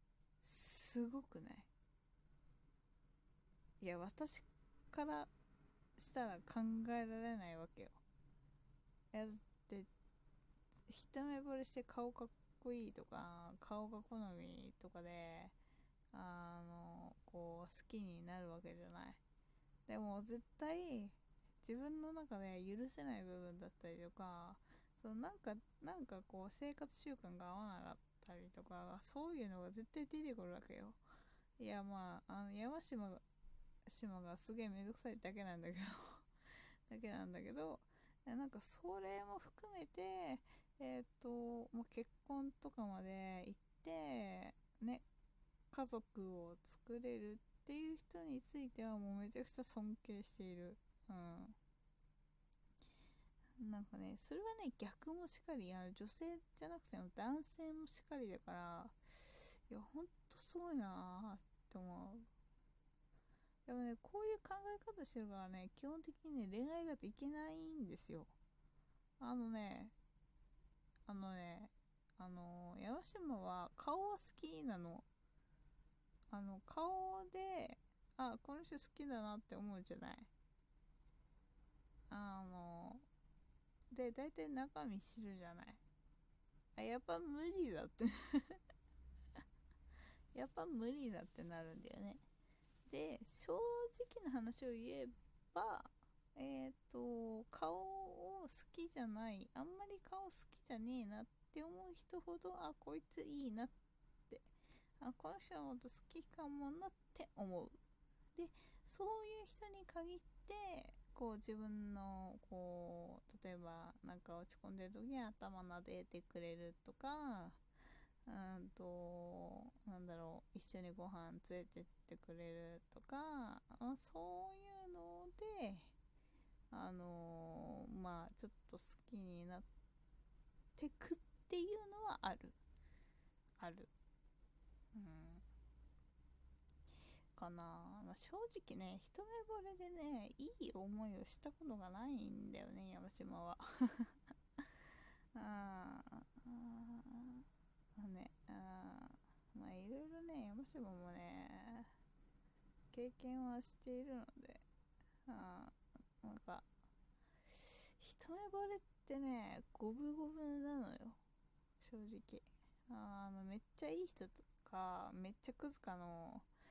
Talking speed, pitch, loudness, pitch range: 225 characters per minute, 225 Hz, -51 LUFS, 180-275 Hz